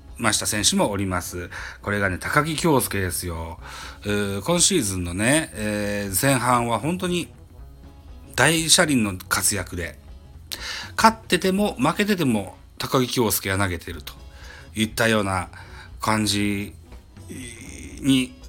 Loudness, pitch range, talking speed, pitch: -22 LUFS, 85-125 Hz, 245 characters per minute, 100 Hz